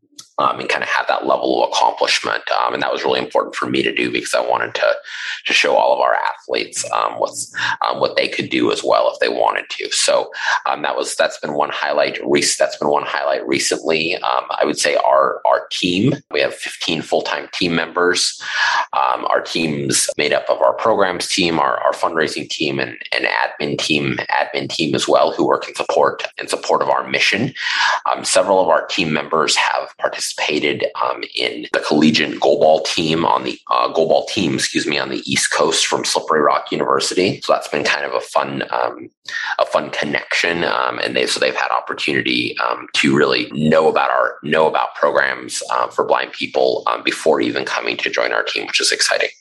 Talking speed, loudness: 210 wpm, -17 LUFS